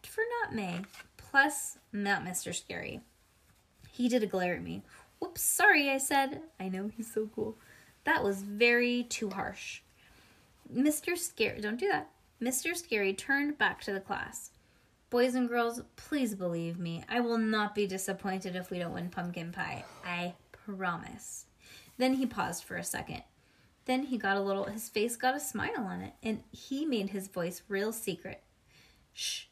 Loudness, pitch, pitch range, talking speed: -33 LUFS, 215 Hz, 190-255 Hz, 170 wpm